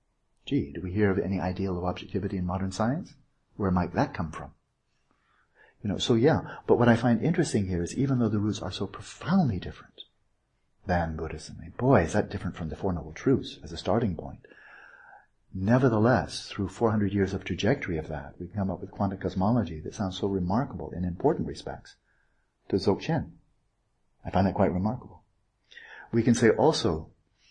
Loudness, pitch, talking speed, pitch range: -28 LUFS, 100 Hz, 185 wpm, 90-115 Hz